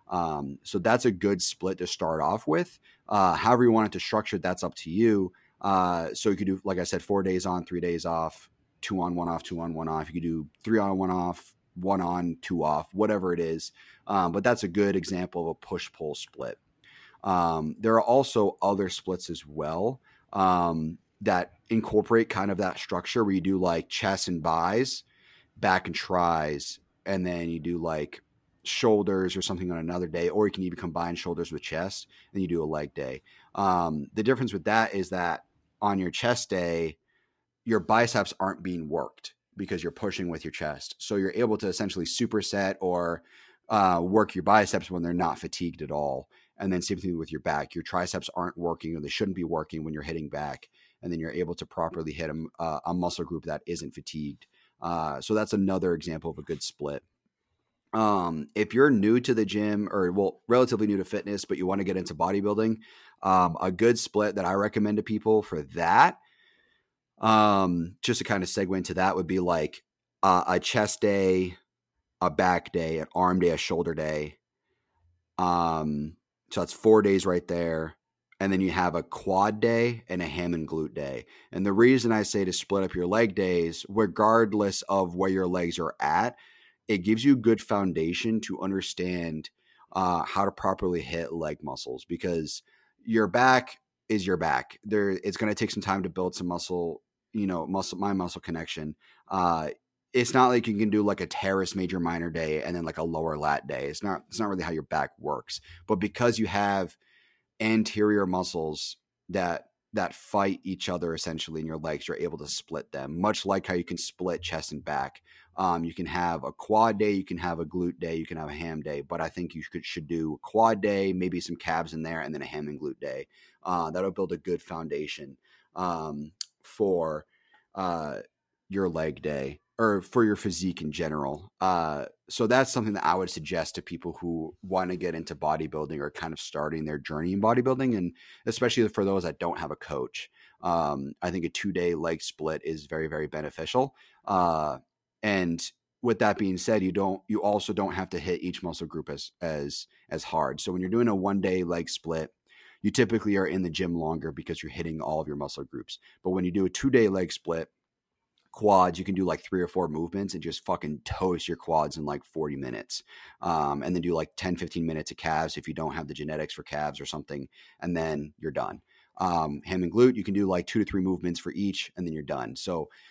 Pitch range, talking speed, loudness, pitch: 80-100 Hz, 210 wpm, -28 LUFS, 90 Hz